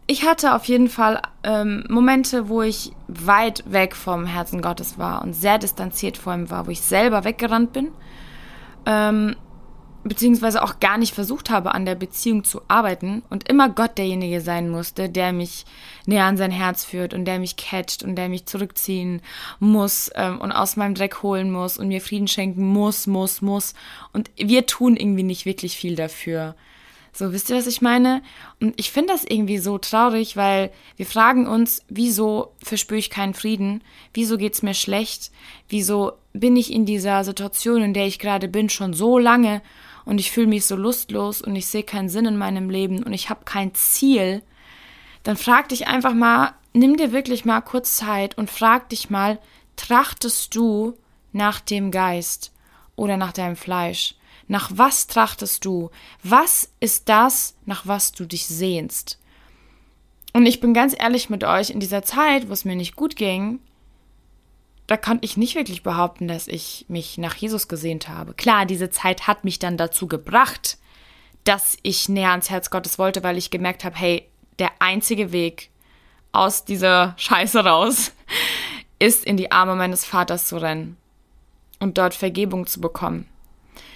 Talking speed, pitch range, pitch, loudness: 175 wpm, 185-225 Hz, 200 Hz, -20 LUFS